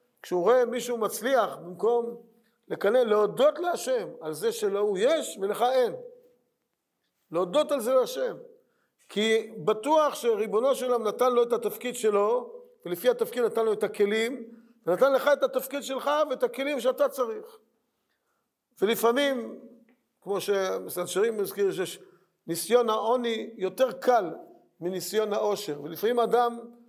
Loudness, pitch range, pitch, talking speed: -27 LUFS, 215-285 Hz, 245 Hz, 125 wpm